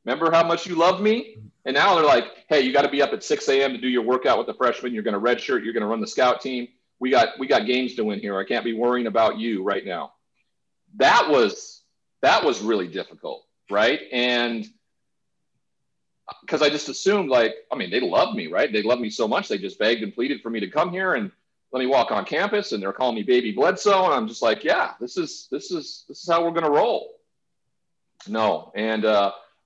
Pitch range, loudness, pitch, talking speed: 120-205 Hz, -22 LUFS, 140 Hz, 240 wpm